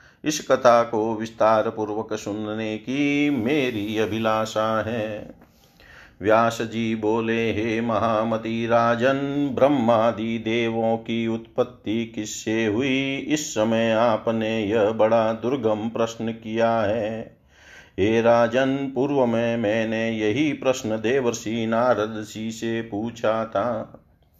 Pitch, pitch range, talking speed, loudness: 115 Hz, 110-115 Hz, 110 wpm, -23 LUFS